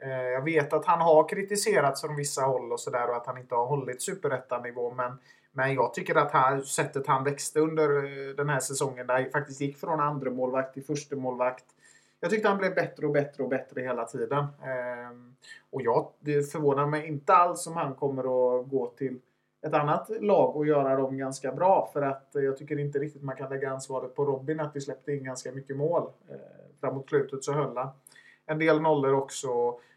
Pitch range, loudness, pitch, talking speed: 130-150 Hz, -28 LUFS, 140 Hz, 205 wpm